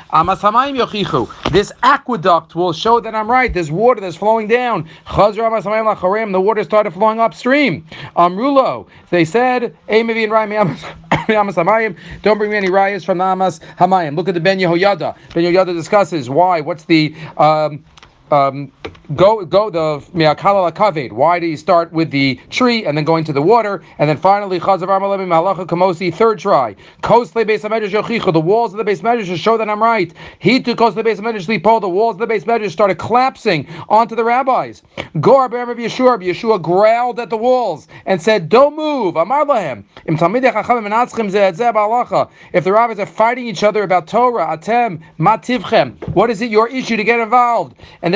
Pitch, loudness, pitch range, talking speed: 210 Hz, -14 LUFS, 175-230 Hz, 150 wpm